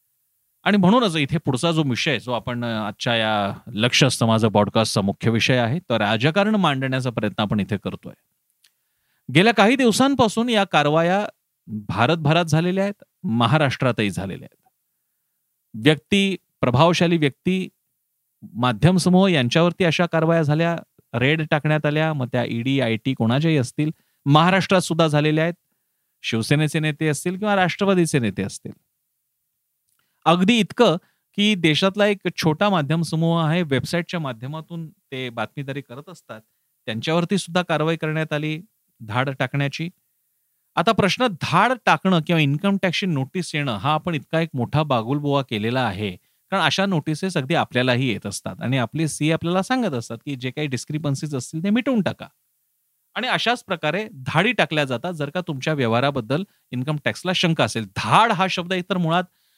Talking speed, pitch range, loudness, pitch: 145 wpm, 125-180 Hz, -21 LUFS, 155 Hz